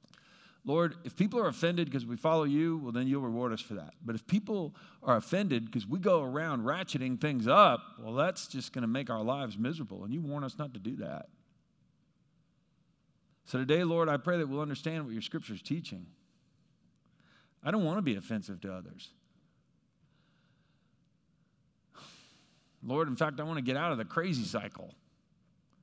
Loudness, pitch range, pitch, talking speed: -33 LUFS, 130-170 Hz, 150 Hz, 180 wpm